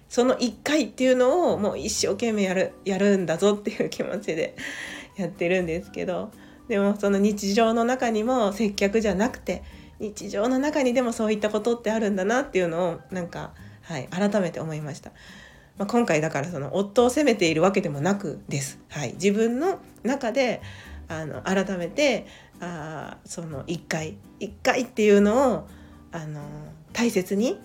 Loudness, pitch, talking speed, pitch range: -25 LUFS, 200 Hz, 325 characters per minute, 165-230 Hz